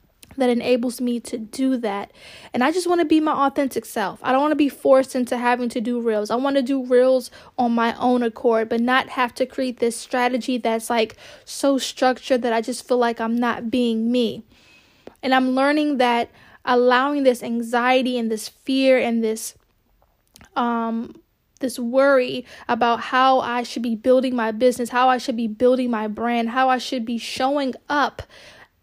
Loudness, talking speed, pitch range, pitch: -21 LUFS, 190 wpm, 235-260 Hz, 250 Hz